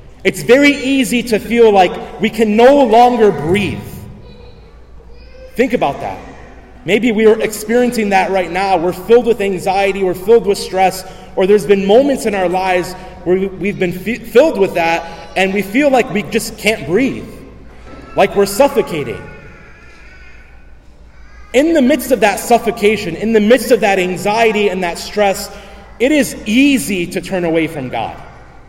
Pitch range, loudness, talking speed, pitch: 185-235 Hz, -13 LUFS, 160 wpm, 205 Hz